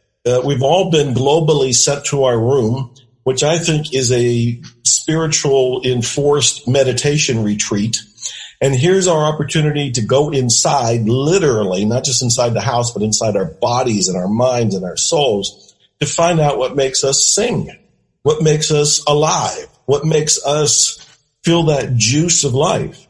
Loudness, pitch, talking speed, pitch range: -14 LUFS, 135 Hz, 155 wpm, 120-150 Hz